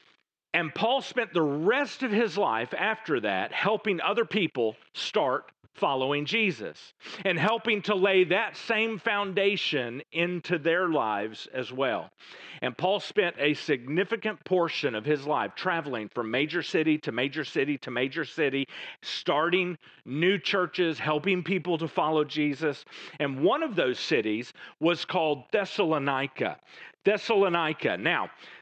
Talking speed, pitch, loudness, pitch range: 135 wpm, 170 Hz, -28 LUFS, 145-195 Hz